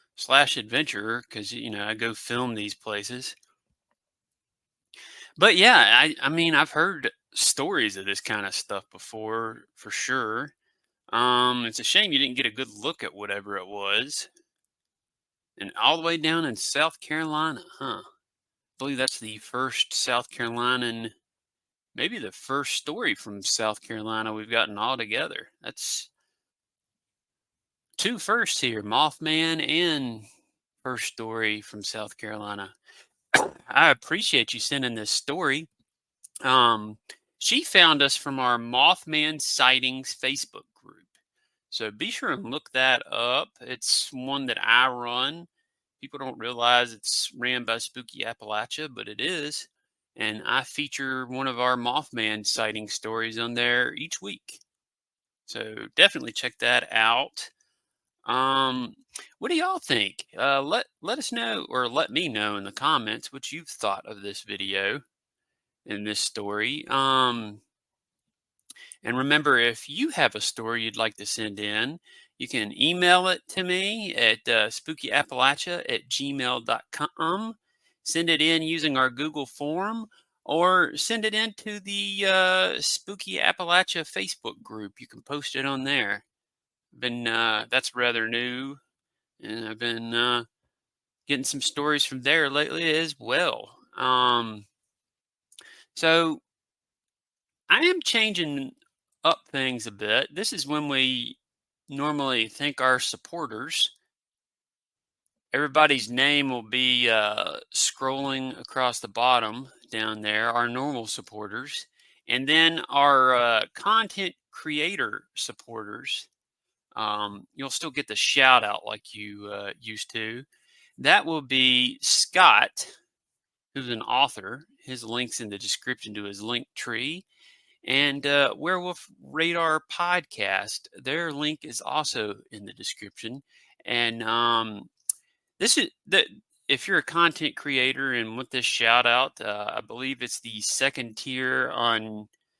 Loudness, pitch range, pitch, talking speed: -24 LUFS, 115-155 Hz, 130 Hz, 135 wpm